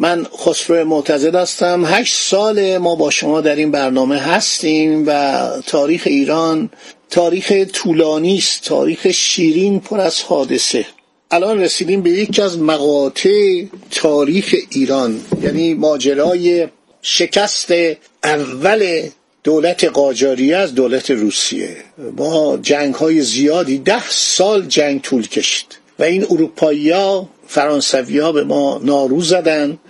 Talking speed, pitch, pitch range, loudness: 120 wpm, 160 Hz, 145-190 Hz, -14 LUFS